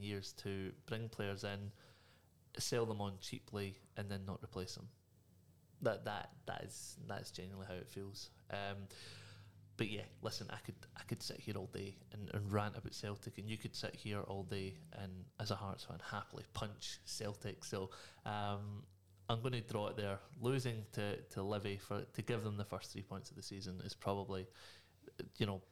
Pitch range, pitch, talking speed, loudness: 95-110 Hz, 100 Hz, 190 wpm, -45 LUFS